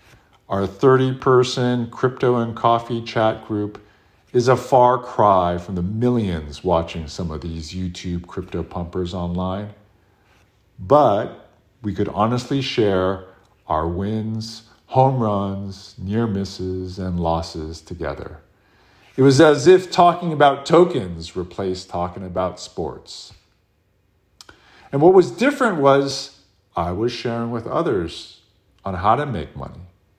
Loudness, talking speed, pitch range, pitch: -20 LUFS, 125 wpm, 90-125 Hz, 100 Hz